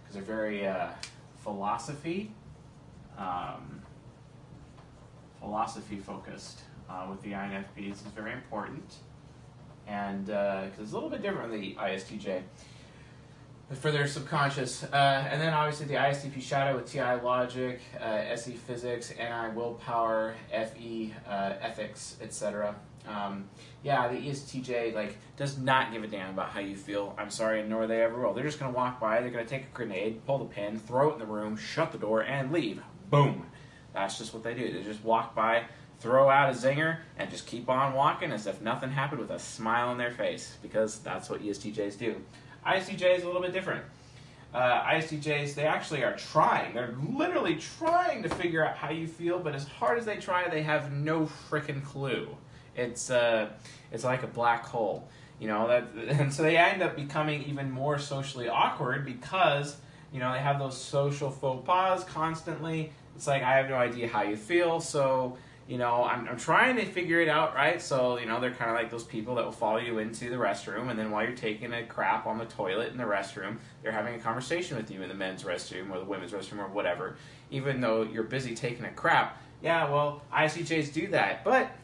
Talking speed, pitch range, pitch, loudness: 195 wpm, 110-145 Hz, 125 Hz, -31 LUFS